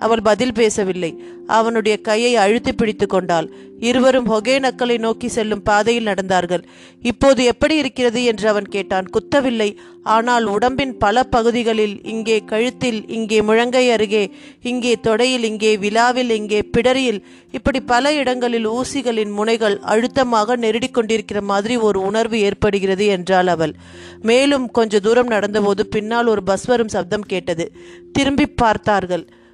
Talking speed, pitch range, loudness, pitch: 125 wpm, 205-245 Hz, -17 LUFS, 225 Hz